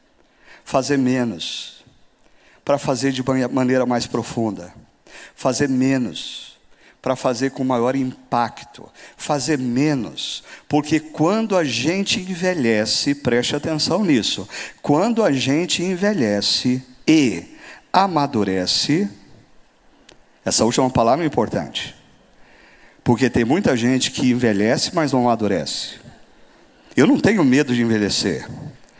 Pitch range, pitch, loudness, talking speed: 120-150 Hz, 130 Hz, -19 LUFS, 105 wpm